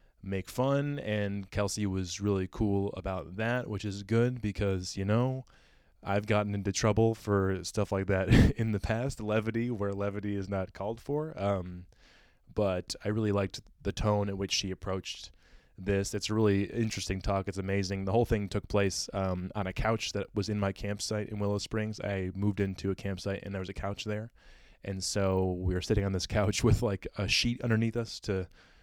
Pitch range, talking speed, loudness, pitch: 95-110 Hz, 200 wpm, -32 LUFS, 100 Hz